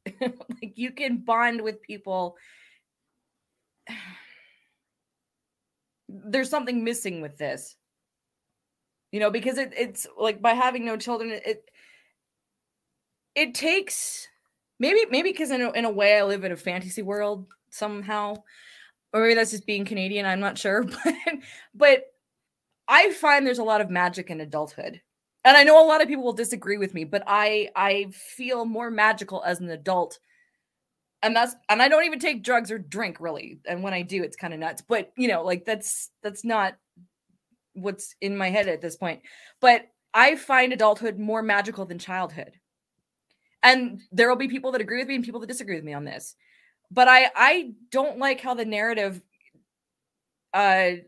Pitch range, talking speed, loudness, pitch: 195-255 Hz, 170 wpm, -23 LUFS, 220 Hz